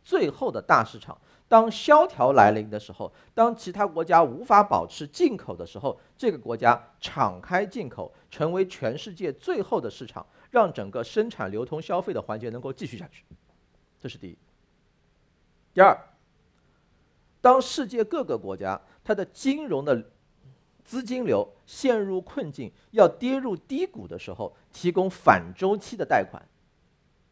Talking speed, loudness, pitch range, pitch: 230 characters per minute, -24 LUFS, 165-260 Hz, 215 Hz